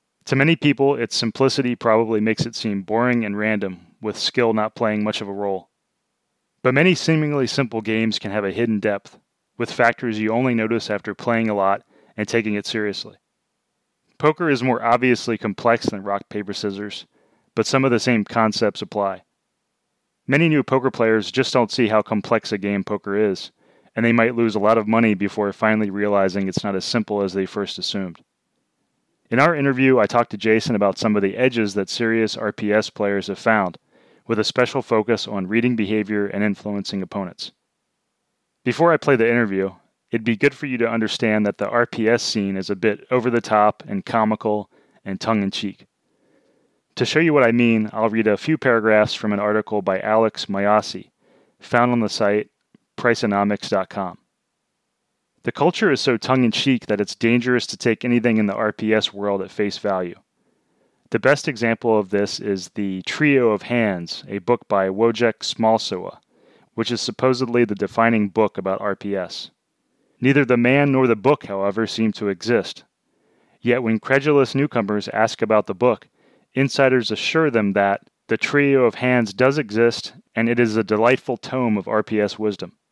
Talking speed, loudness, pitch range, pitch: 175 wpm, -20 LUFS, 105-120 Hz, 110 Hz